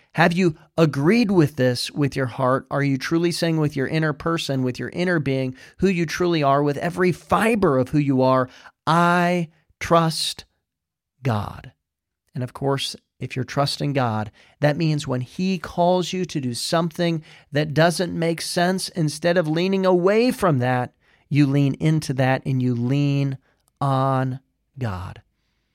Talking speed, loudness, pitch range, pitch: 160 wpm, -21 LUFS, 130-170 Hz, 145 Hz